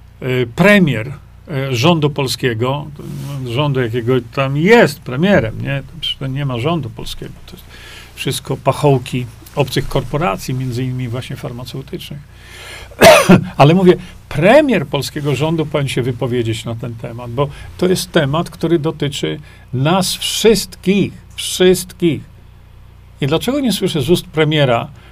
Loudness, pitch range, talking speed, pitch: -15 LUFS, 125-160 Hz, 120 wpm, 140 Hz